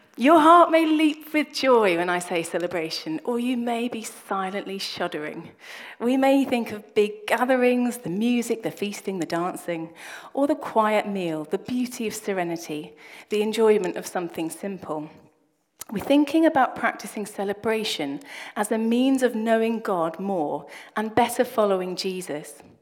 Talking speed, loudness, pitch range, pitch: 150 wpm, -24 LUFS, 175-245 Hz, 210 Hz